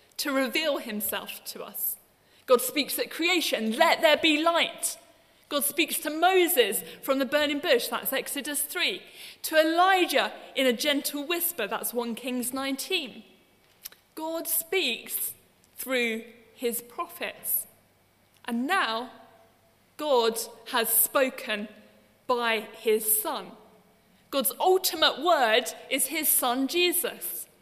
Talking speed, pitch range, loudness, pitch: 115 wpm, 235-330 Hz, -26 LUFS, 280 Hz